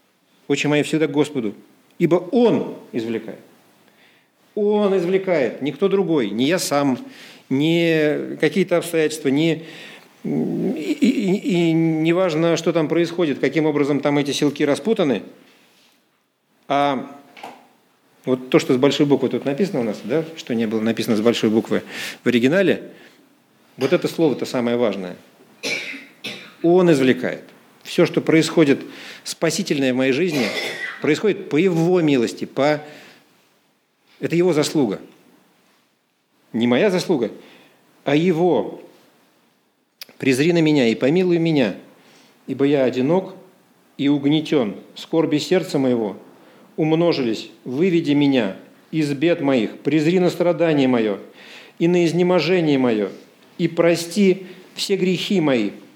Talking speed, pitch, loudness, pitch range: 125 wpm, 160 Hz, -19 LUFS, 140-180 Hz